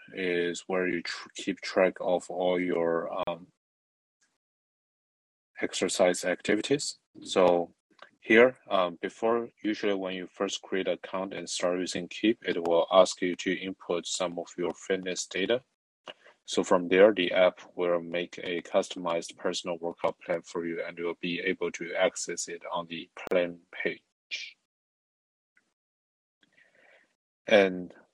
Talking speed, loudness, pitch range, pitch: 135 wpm, -29 LUFS, 85-95 Hz, 90 Hz